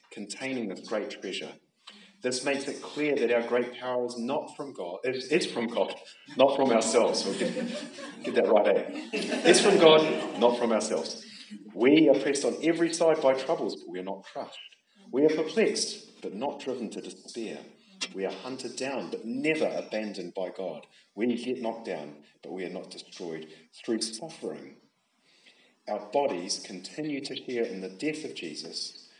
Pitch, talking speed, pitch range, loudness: 135 Hz, 175 wpm, 115-165 Hz, -28 LUFS